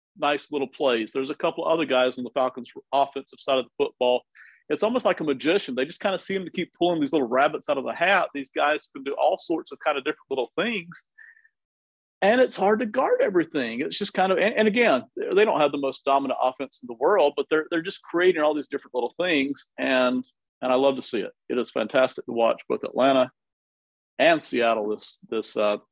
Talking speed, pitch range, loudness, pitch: 230 wpm, 130-205 Hz, -24 LUFS, 150 Hz